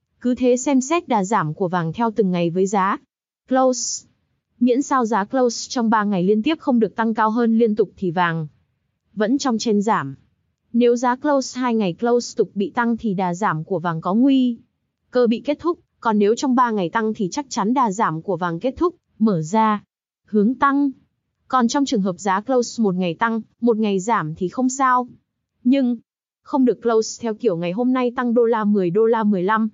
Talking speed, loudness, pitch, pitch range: 215 wpm, -20 LUFS, 230 Hz, 195-250 Hz